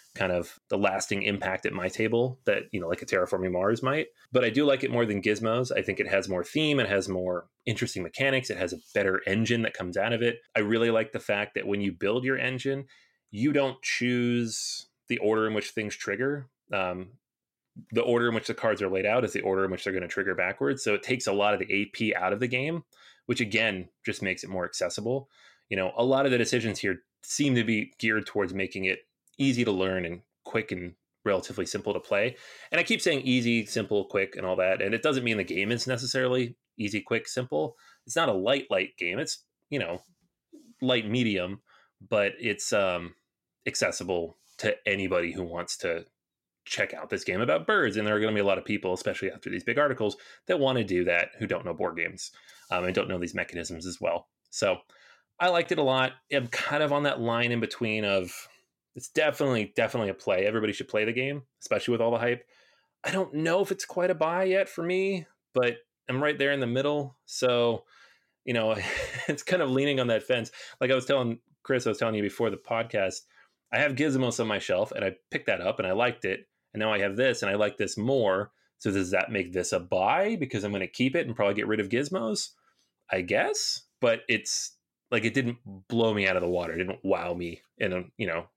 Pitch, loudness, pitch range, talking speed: 115 Hz, -28 LUFS, 100-130 Hz, 235 wpm